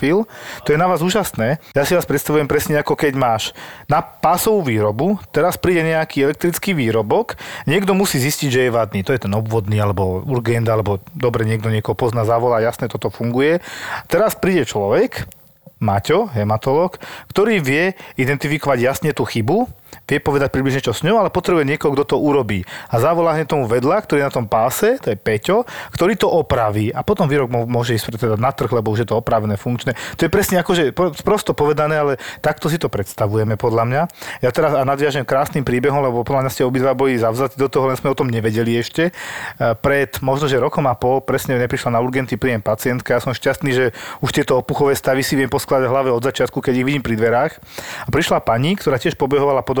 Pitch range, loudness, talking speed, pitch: 120-150 Hz, -18 LUFS, 200 wpm, 135 Hz